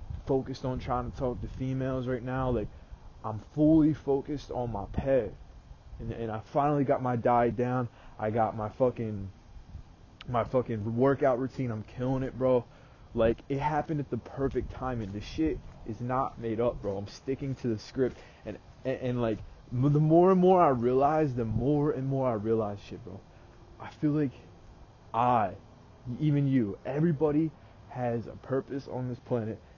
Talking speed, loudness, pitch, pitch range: 175 wpm, -30 LUFS, 125 Hz, 110-135 Hz